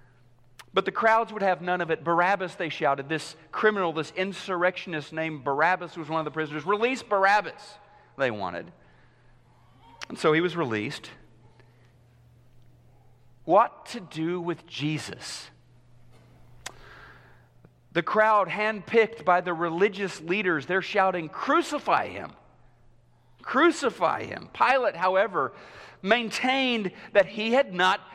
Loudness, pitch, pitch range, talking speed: -26 LUFS, 175 Hz, 125-200 Hz, 120 wpm